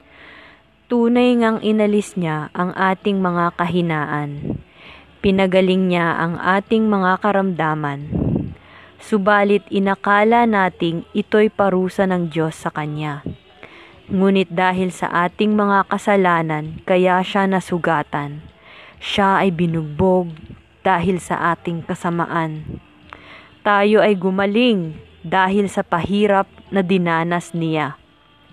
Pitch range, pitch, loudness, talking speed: 165-200 Hz, 185 Hz, -18 LUFS, 100 wpm